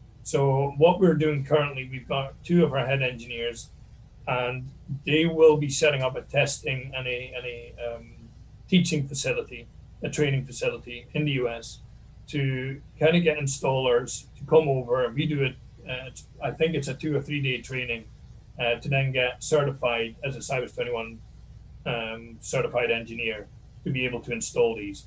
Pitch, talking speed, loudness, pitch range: 130 Hz, 170 wpm, -26 LUFS, 120-145 Hz